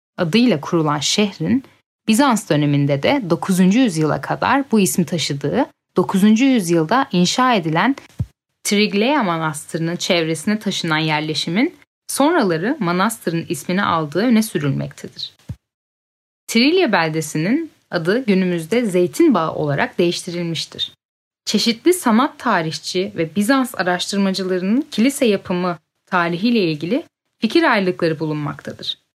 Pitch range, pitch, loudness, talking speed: 170-235 Hz, 185 Hz, -18 LUFS, 95 wpm